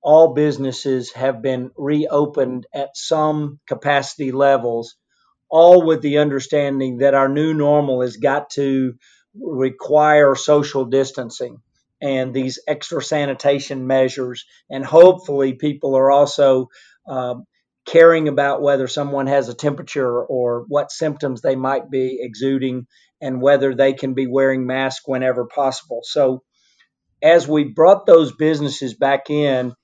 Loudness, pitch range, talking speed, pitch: -17 LUFS, 130-145 Hz, 130 wpm, 140 Hz